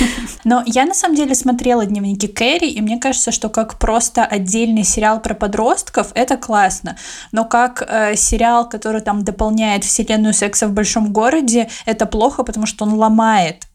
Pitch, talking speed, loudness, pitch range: 225 Hz, 165 wpm, -15 LUFS, 215-240 Hz